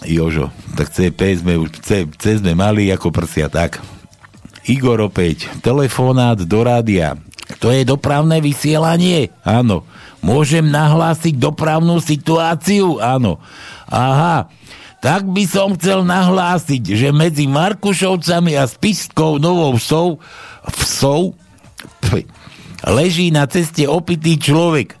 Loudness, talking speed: -15 LUFS, 110 wpm